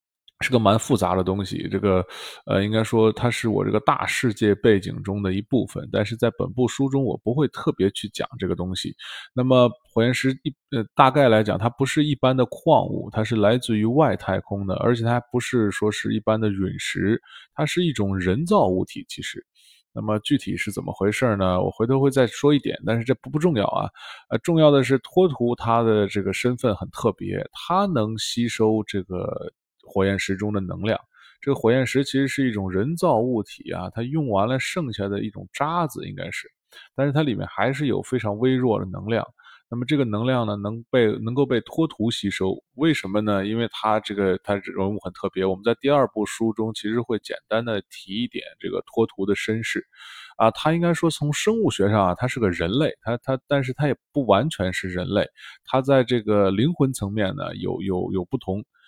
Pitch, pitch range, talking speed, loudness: 115 Hz, 100-130 Hz, 300 characters per minute, -23 LUFS